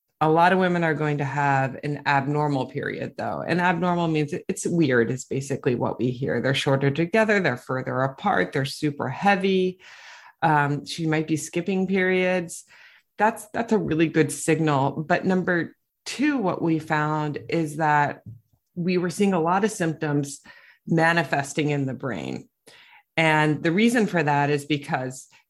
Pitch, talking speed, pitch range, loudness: 155 Hz, 165 wpm, 140-180 Hz, -23 LUFS